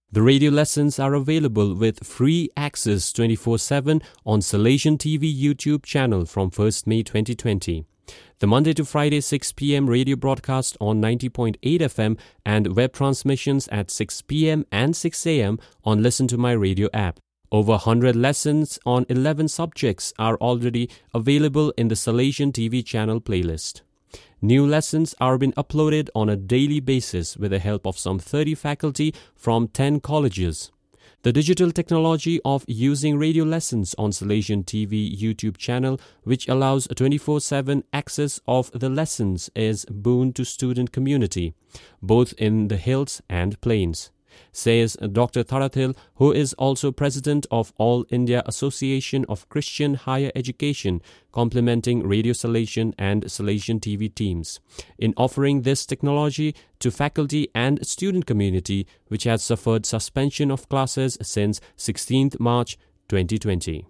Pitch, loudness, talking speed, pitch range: 125 Hz, -22 LUFS, 135 wpm, 105-140 Hz